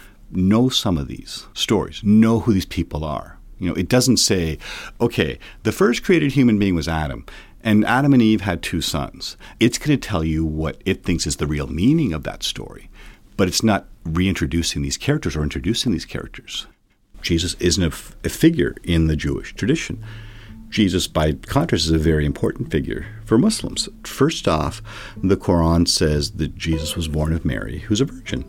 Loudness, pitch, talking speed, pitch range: -20 LUFS, 90 Hz, 185 wpm, 80-110 Hz